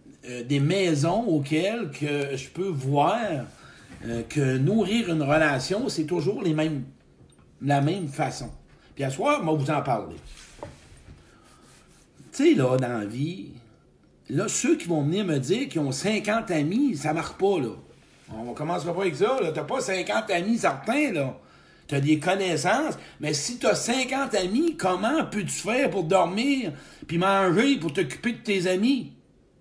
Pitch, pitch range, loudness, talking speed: 170 Hz, 145-205 Hz, -25 LUFS, 170 wpm